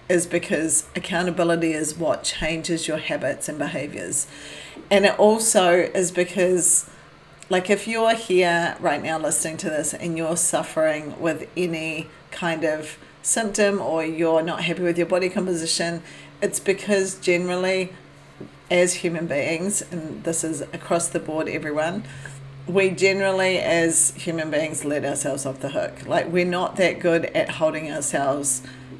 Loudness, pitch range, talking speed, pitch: -22 LUFS, 160-185 Hz, 145 wpm, 170 Hz